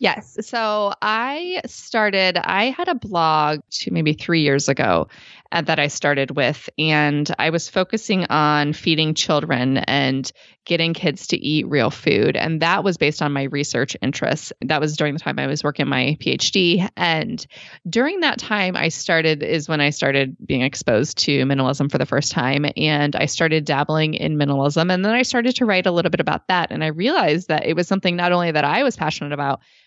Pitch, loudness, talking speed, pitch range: 155 Hz, -19 LUFS, 200 wpm, 145-185 Hz